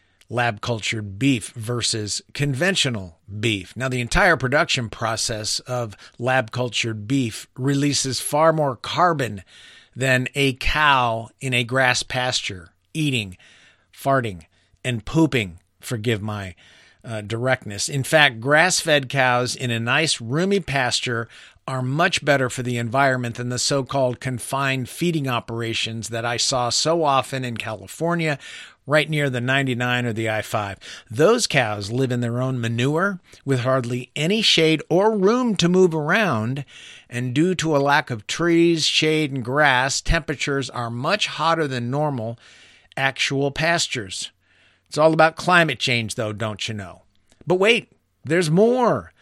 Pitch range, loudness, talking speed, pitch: 115-150 Hz, -21 LUFS, 145 wpm, 130 Hz